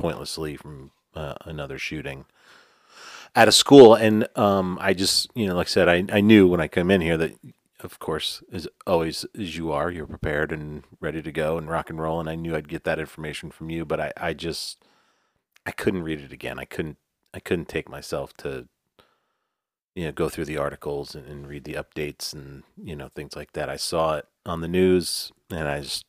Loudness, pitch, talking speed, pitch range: -23 LUFS, 85 Hz, 215 wpm, 75-95 Hz